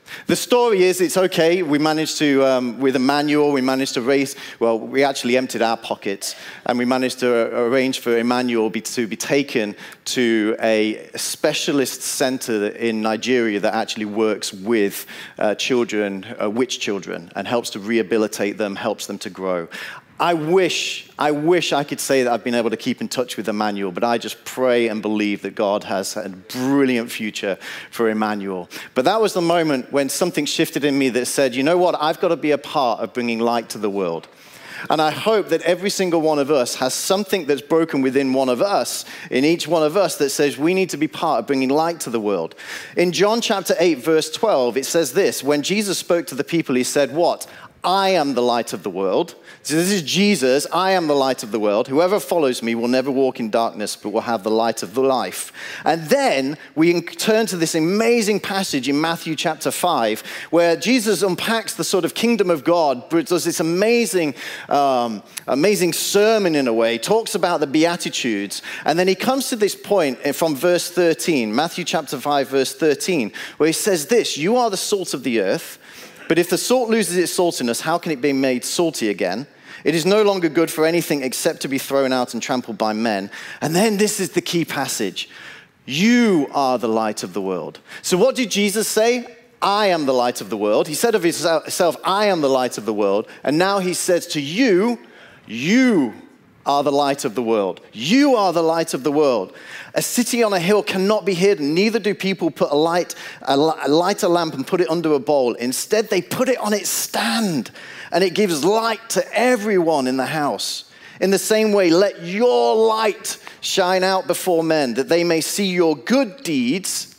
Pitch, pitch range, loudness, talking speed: 155 Hz, 125-190 Hz, -19 LUFS, 210 wpm